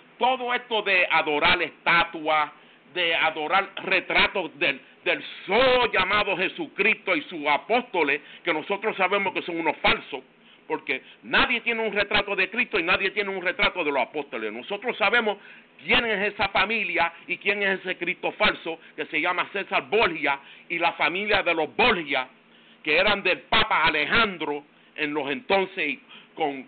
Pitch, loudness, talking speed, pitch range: 190 Hz, -23 LUFS, 155 wpm, 170-215 Hz